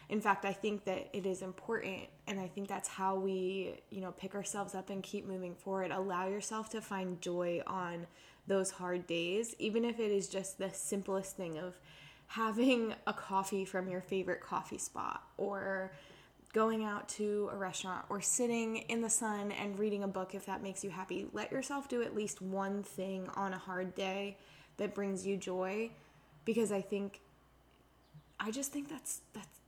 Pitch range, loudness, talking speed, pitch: 185-210 Hz, -38 LUFS, 185 wpm, 195 Hz